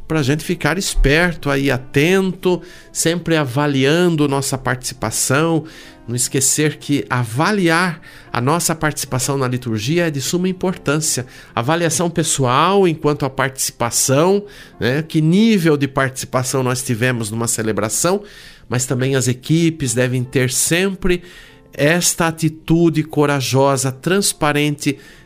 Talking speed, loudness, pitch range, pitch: 115 wpm, -17 LUFS, 130-165 Hz, 145 Hz